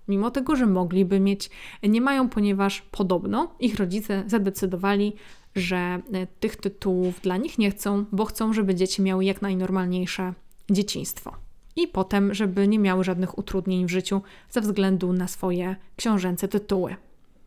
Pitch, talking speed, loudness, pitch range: 195 Hz, 145 wpm, -25 LUFS, 185-210 Hz